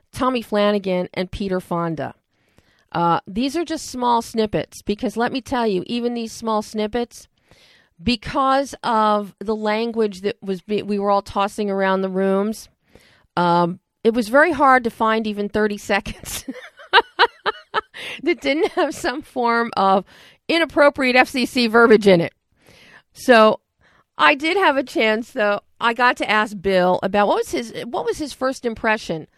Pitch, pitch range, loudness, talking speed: 220 Hz, 200-255 Hz, -19 LUFS, 155 wpm